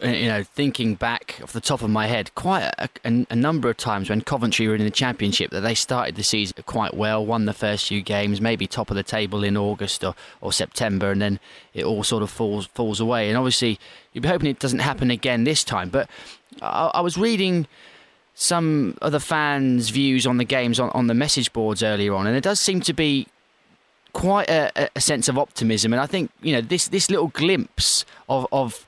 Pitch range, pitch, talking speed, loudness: 105-140 Hz, 120 Hz, 225 wpm, -22 LUFS